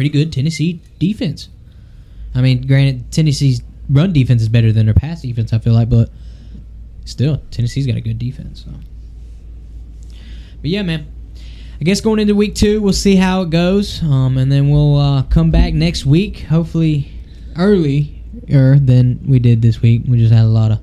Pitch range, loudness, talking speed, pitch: 115-160 Hz, -14 LUFS, 180 wpm, 130 Hz